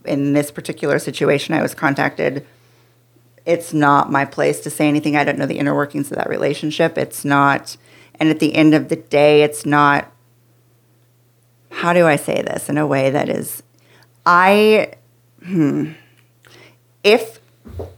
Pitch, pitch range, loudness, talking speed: 145 Hz, 120-155 Hz, -16 LUFS, 155 wpm